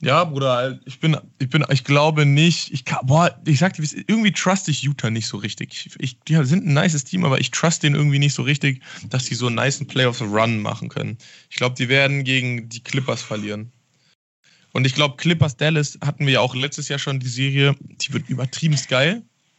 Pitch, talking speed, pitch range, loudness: 140 Hz, 205 wpm, 130-155 Hz, -20 LUFS